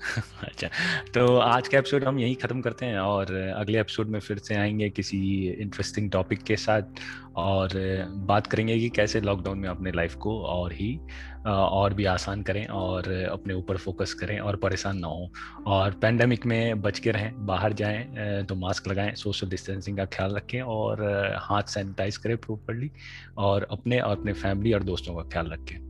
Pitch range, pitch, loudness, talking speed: 95-110 Hz, 100 Hz, -27 LUFS, 180 wpm